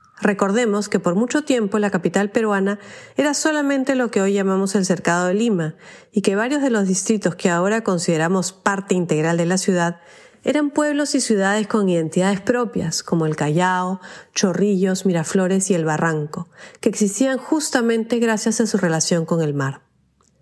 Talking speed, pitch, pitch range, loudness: 170 wpm, 200 Hz, 180-230 Hz, -19 LUFS